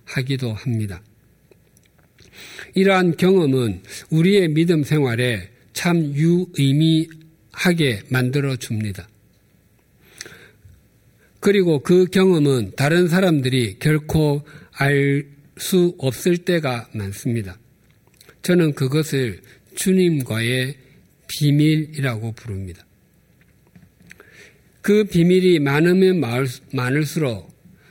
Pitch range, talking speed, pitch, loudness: 125-170 Hz, 185 characters per minute, 145 Hz, -19 LUFS